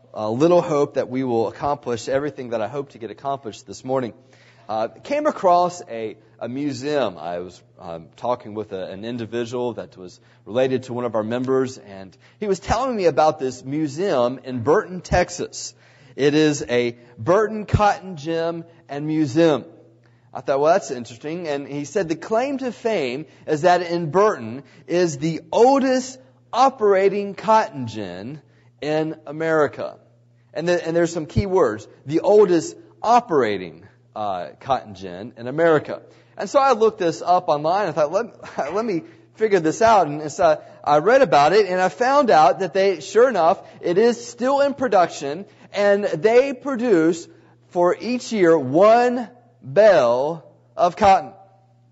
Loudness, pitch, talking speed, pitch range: -20 LUFS, 155 Hz, 165 wpm, 125-195 Hz